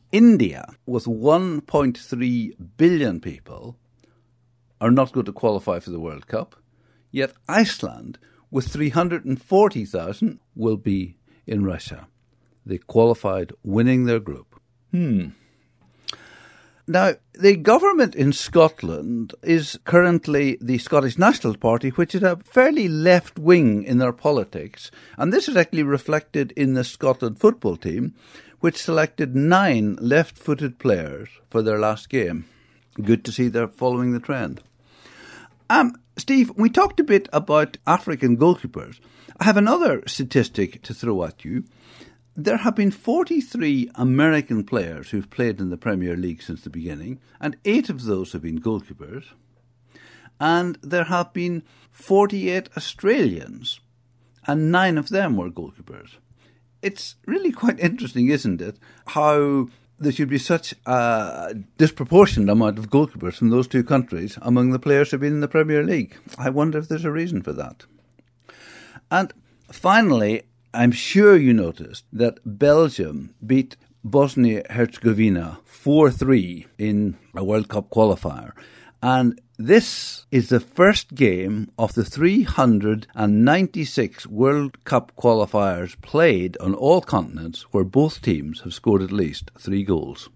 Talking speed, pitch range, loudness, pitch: 135 wpm, 115-155 Hz, -20 LUFS, 125 Hz